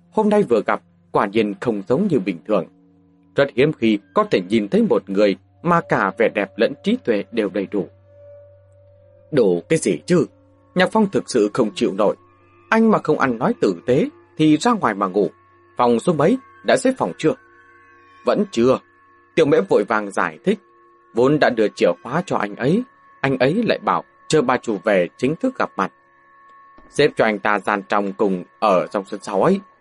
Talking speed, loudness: 200 wpm, -19 LUFS